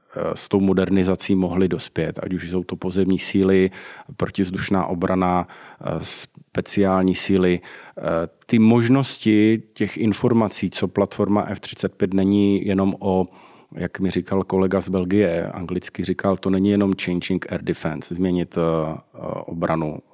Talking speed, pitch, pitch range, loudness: 120 wpm, 95 Hz, 90-100 Hz, -21 LUFS